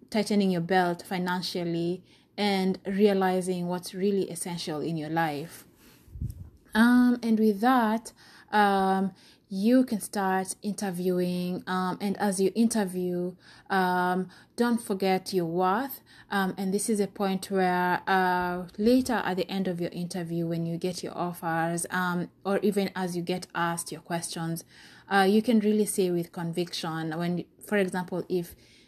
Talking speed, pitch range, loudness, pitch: 150 wpm, 175-200 Hz, -28 LUFS, 185 Hz